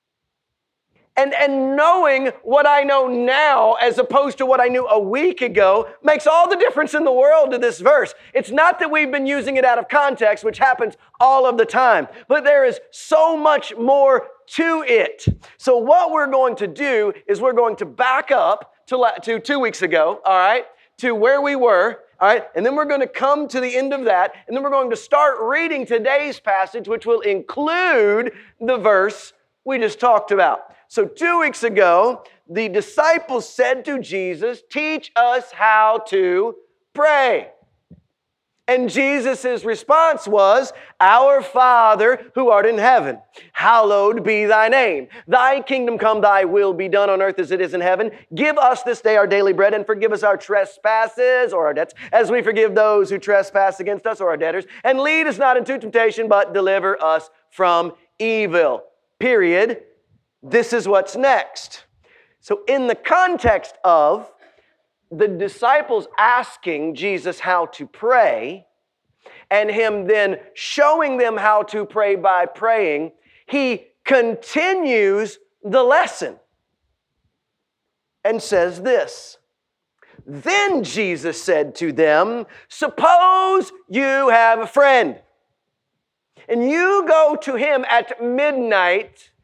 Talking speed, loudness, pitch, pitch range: 155 wpm, -17 LUFS, 250 Hz, 210-290 Hz